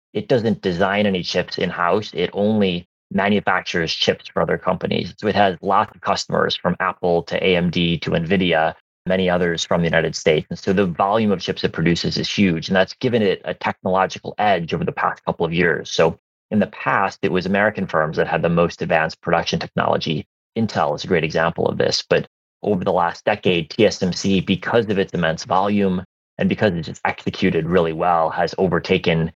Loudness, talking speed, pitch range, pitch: -20 LUFS, 195 wpm, 85-95 Hz, 90 Hz